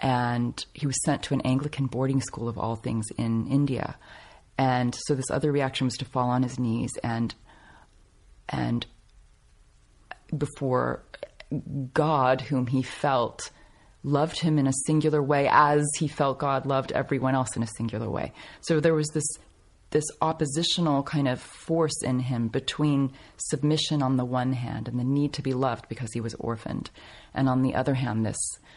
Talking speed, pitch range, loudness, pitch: 170 wpm, 120-145 Hz, -27 LUFS, 130 Hz